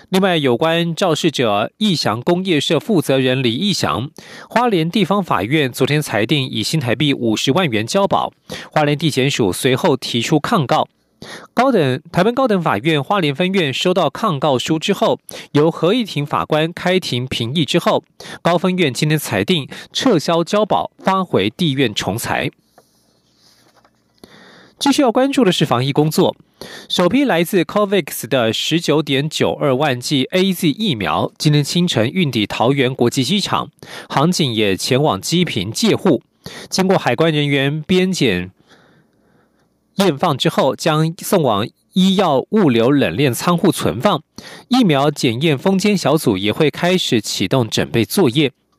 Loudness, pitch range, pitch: -16 LUFS, 135-185 Hz, 160 Hz